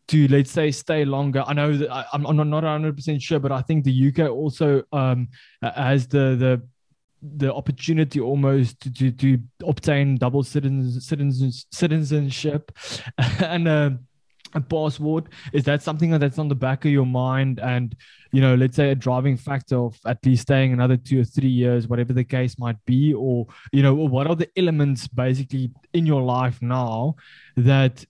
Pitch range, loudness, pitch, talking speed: 130-150 Hz, -21 LUFS, 135 Hz, 175 wpm